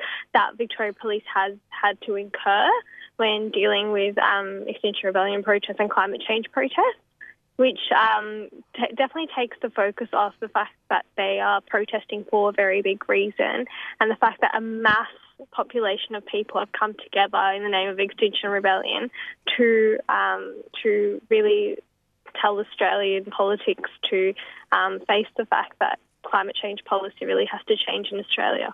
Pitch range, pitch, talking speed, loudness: 200-250 Hz, 215 Hz, 160 wpm, -23 LUFS